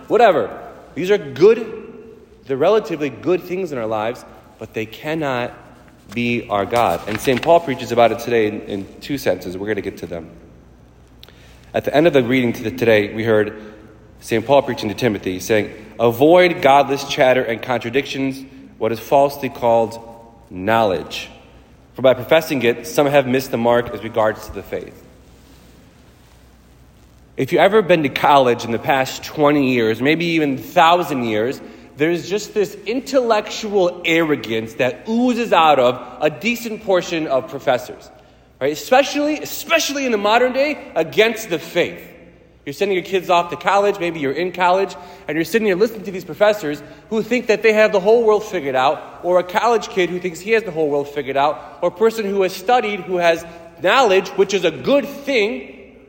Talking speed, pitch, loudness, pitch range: 180 wpm, 145 Hz, -18 LUFS, 115-195 Hz